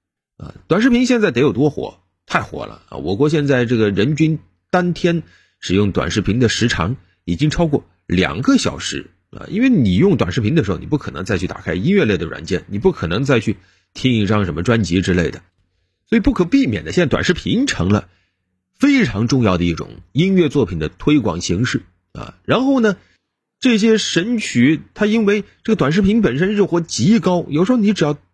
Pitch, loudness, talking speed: 145 Hz, -17 LUFS, 295 characters per minute